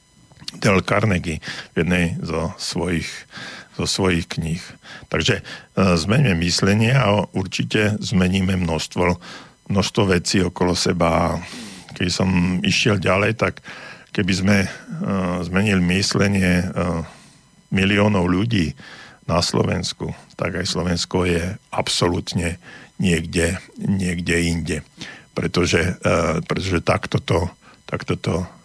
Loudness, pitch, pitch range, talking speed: -20 LUFS, 90 Hz, 85-95 Hz, 95 wpm